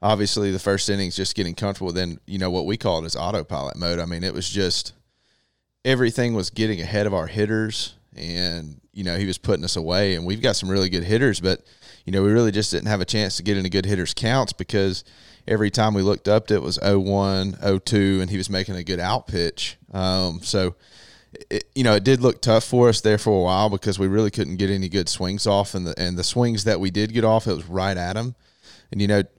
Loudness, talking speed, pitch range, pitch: -22 LUFS, 245 wpm, 90-110 Hz, 100 Hz